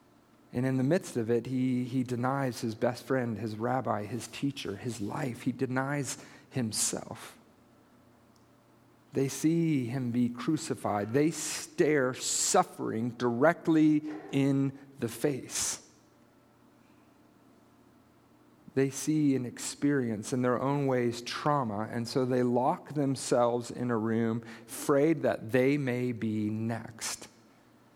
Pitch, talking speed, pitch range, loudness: 125 Hz, 120 wpm, 115-140 Hz, -30 LUFS